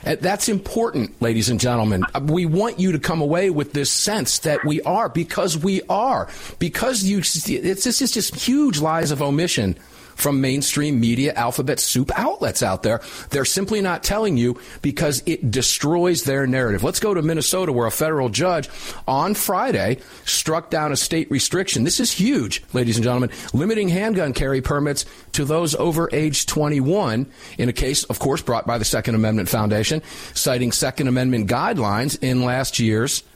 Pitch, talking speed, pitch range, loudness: 145 Hz, 175 wpm, 125-175 Hz, -20 LUFS